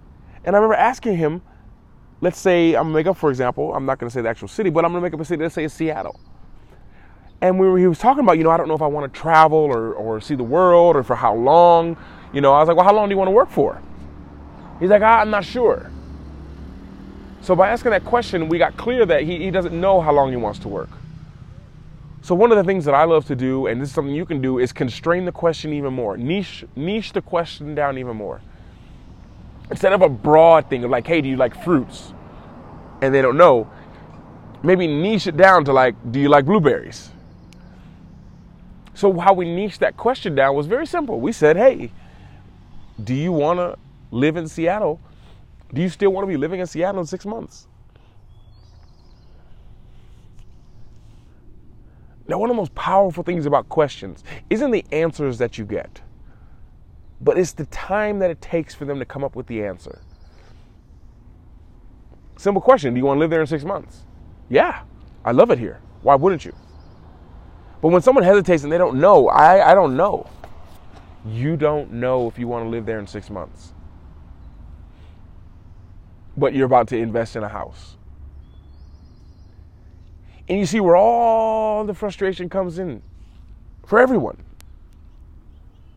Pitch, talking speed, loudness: 140 Hz, 190 wpm, -18 LUFS